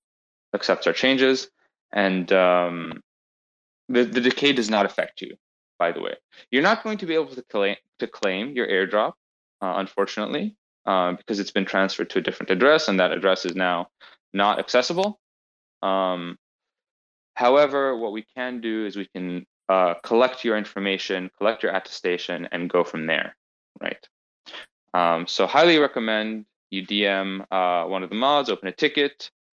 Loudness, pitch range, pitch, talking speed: -23 LUFS, 90-130 Hz, 100 Hz, 165 wpm